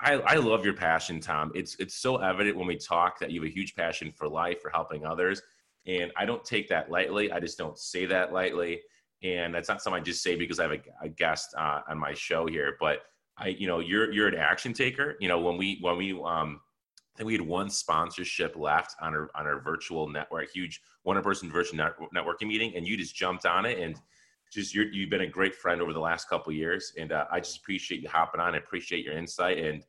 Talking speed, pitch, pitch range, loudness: 250 wpm, 90 Hz, 85-100 Hz, -30 LUFS